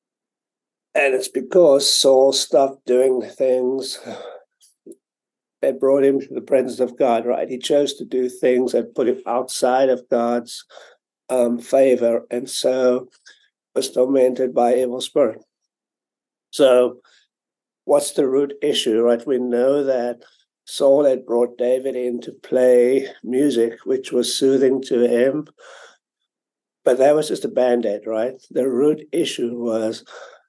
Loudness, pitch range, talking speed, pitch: -19 LUFS, 120-135 Hz, 140 wpm, 125 Hz